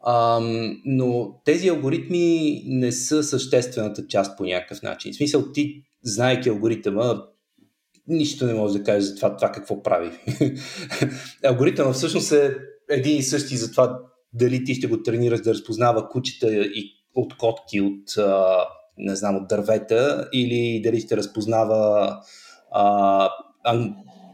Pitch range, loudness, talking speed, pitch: 105-130 Hz, -22 LUFS, 135 wpm, 120 Hz